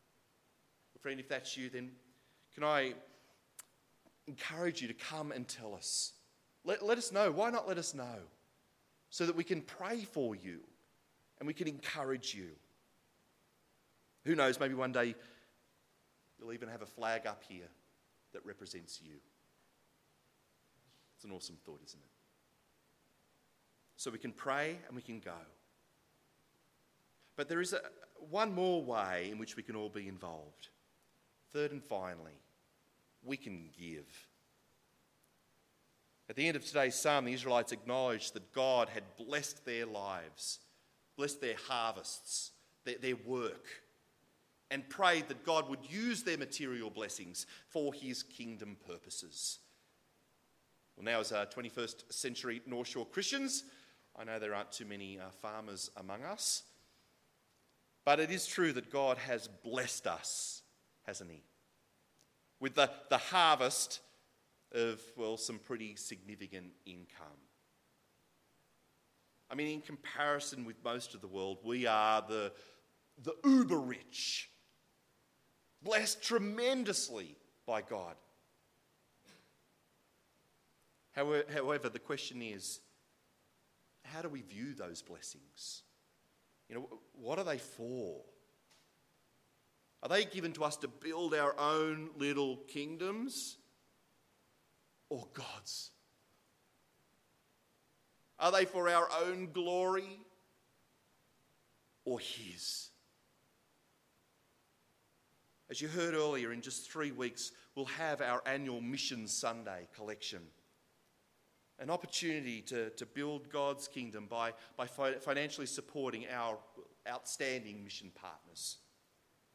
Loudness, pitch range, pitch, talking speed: -38 LUFS, 110-155 Hz, 130 Hz, 125 wpm